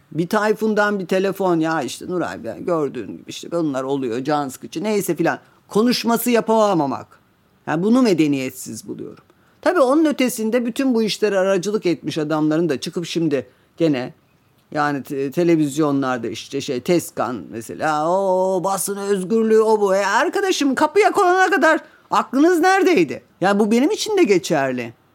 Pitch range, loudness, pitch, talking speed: 155-235 Hz, -19 LUFS, 195 Hz, 145 wpm